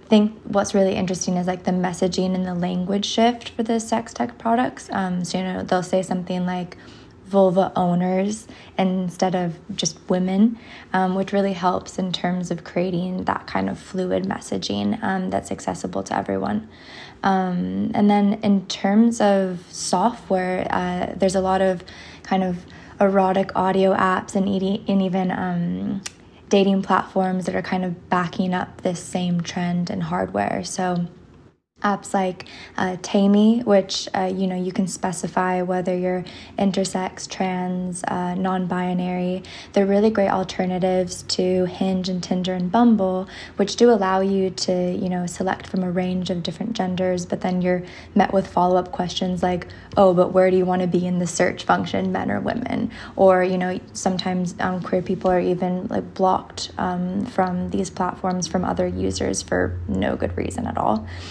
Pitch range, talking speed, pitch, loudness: 180-195 Hz, 170 wpm, 185 Hz, -22 LUFS